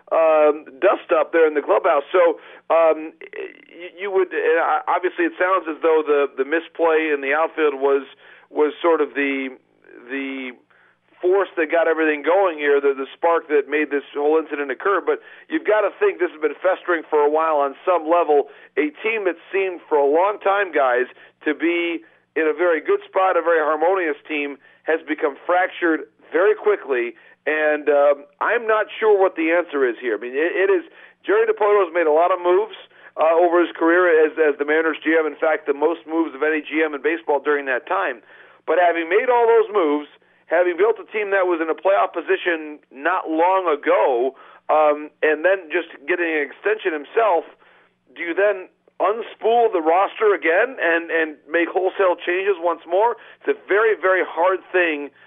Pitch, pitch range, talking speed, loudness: 175 Hz, 155-220 Hz, 190 wpm, -19 LUFS